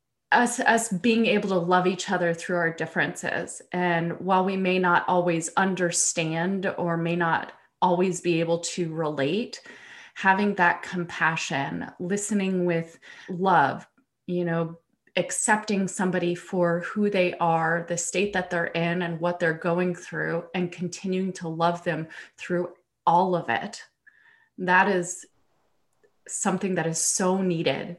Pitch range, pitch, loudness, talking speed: 170-190 Hz, 180 Hz, -25 LUFS, 140 wpm